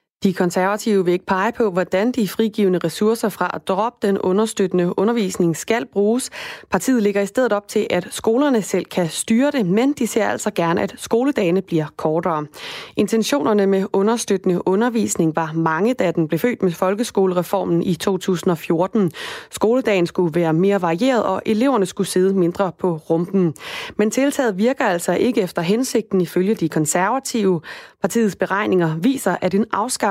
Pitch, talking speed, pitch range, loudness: 195 Hz, 160 wpm, 180-225 Hz, -19 LUFS